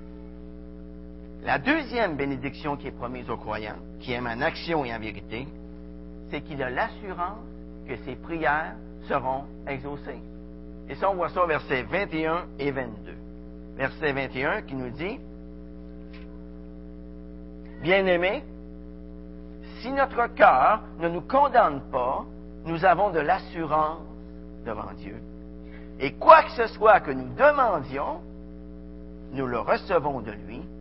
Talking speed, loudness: 130 wpm, -25 LUFS